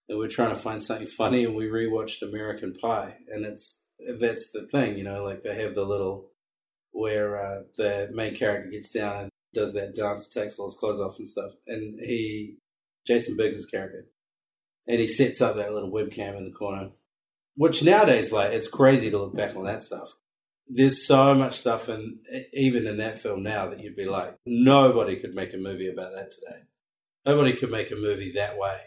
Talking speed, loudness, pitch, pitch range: 200 wpm, -26 LUFS, 110 Hz, 100-120 Hz